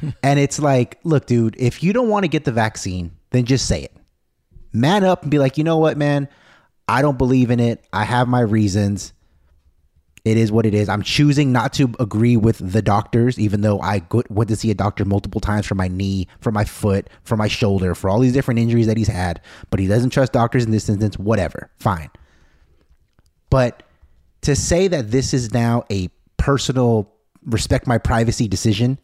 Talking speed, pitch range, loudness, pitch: 205 wpm, 95-130 Hz, -18 LUFS, 110 Hz